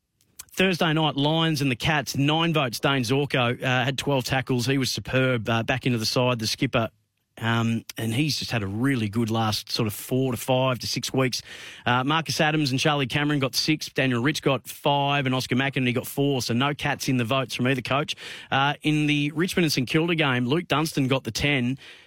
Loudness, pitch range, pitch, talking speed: -24 LUFS, 125-145 Hz, 135 Hz, 220 wpm